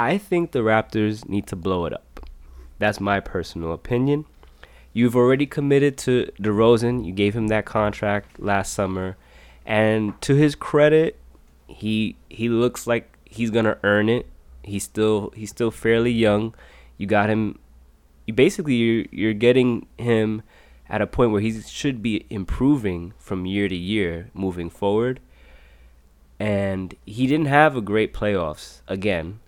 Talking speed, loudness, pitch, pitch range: 150 wpm, -22 LUFS, 105 Hz, 95-120 Hz